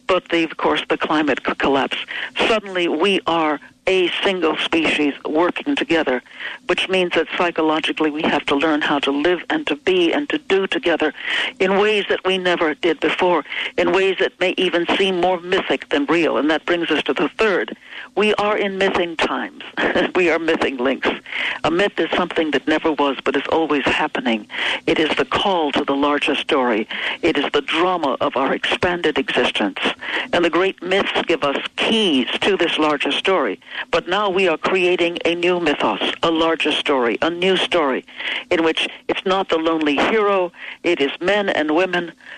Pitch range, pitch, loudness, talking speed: 155-190 Hz, 175 Hz, -19 LUFS, 185 wpm